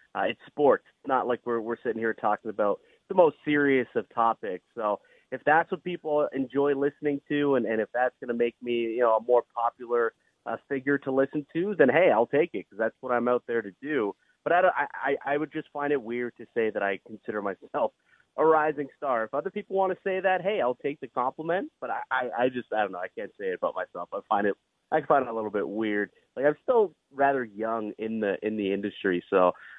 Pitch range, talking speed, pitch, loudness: 115-150 Hz, 245 wpm, 130 Hz, -28 LUFS